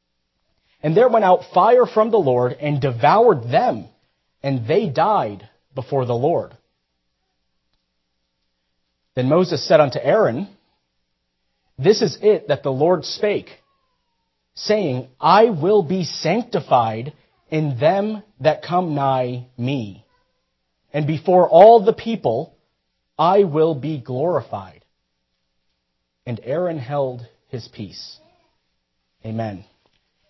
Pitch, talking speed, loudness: 130 Hz, 110 wpm, -18 LUFS